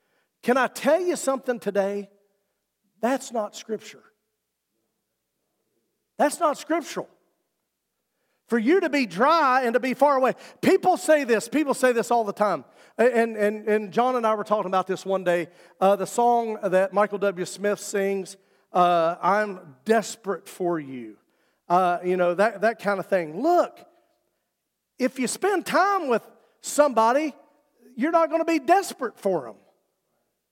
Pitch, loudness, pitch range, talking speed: 225 Hz, -23 LUFS, 200-285 Hz, 155 wpm